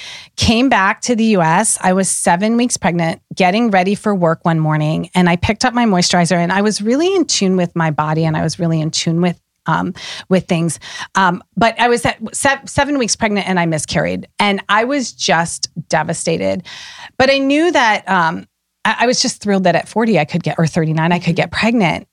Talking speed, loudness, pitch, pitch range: 220 wpm, -15 LUFS, 185 Hz, 165-225 Hz